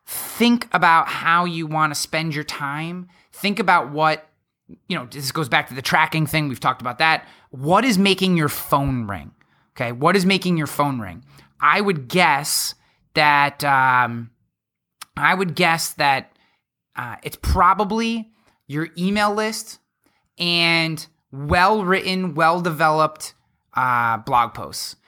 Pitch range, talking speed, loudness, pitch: 140-180 Hz, 145 wpm, -19 LUFS, 155 Hz